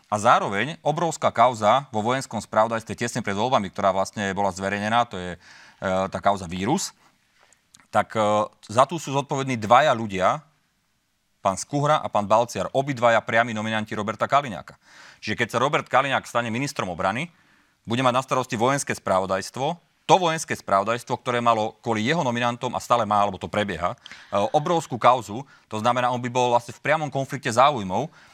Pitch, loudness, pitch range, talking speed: 120 Hz, -23 LUFS, 105-130 Hz, 165 wpm